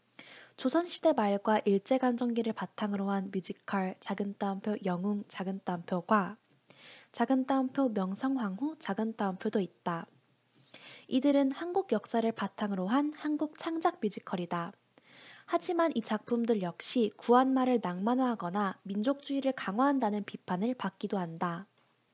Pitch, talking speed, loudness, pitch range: 215 Hz, 295 characters per minute, -32 LUFS, 195-265 Hz